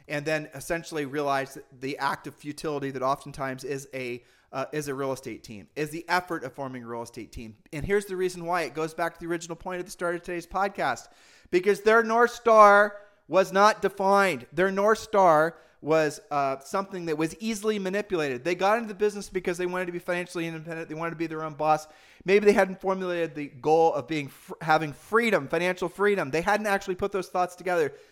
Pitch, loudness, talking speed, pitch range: 170 Hz, -26 LUFS, 215 wpm, 150-195 Hz